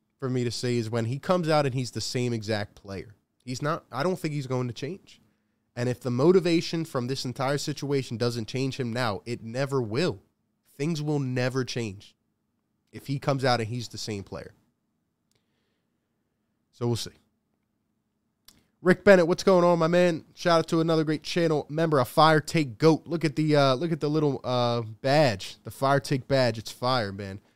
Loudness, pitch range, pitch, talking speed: -26 LUFS, 110-150 Hz, 130 Hz, 195 wpm